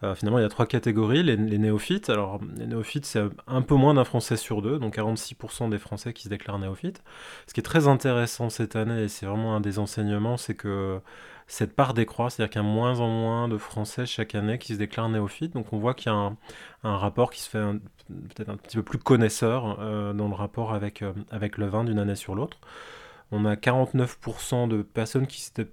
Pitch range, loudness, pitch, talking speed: 105-120 Hz, -27 LUFS, 110 Hz, 235 wpm